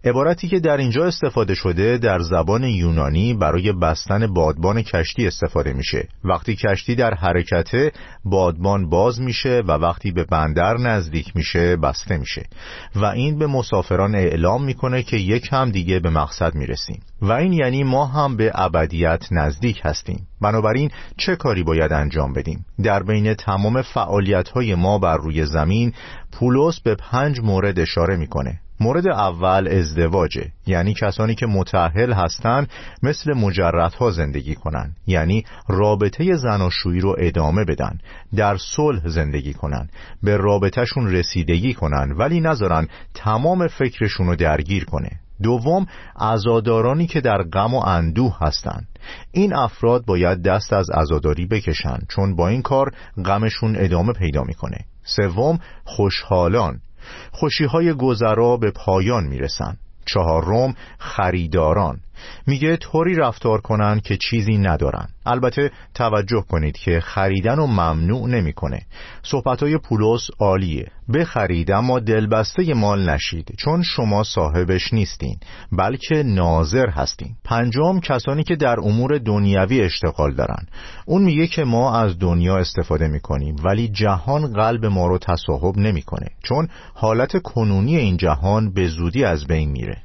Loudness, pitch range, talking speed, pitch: -19 LUFS, 85-120 Hz, 135 wpm, 100 Hz